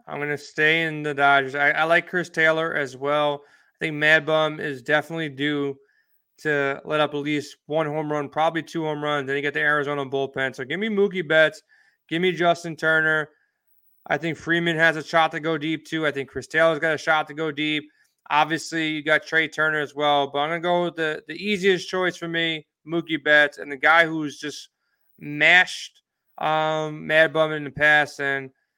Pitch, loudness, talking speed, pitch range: 155 Hz, -22 LUFS, 215 wpm, 145-160 Hz